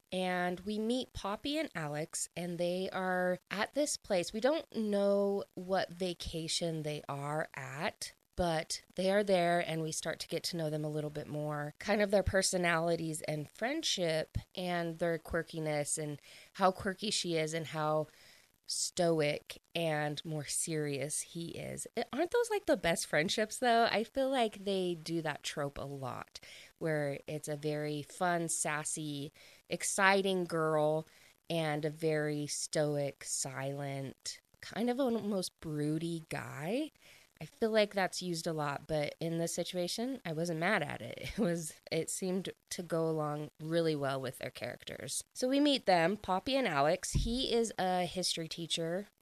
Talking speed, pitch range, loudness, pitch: 160 wpm, 155-195 Hz, -35 LUFS, 170 Hz